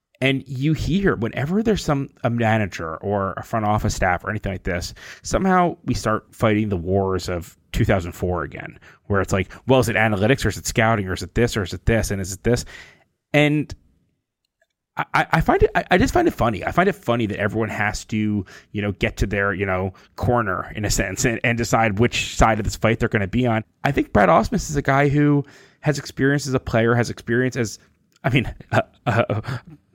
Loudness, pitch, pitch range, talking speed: -21 LUFS, 115 Hz, 100-130 Hz, 220 wpm